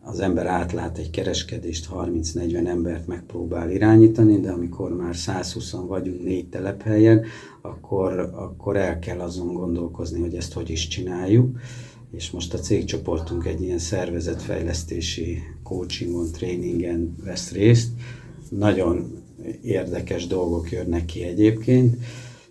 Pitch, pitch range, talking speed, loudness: 90 Hz, 85-105 Hz, 115 wpm, -23 LUFS